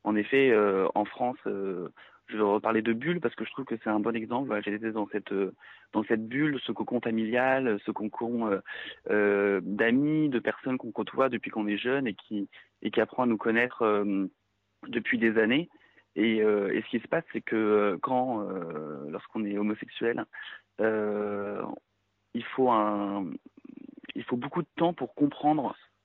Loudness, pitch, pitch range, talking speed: -29 LUFS, 110 Hz, 105-125 Hz, 190 wpm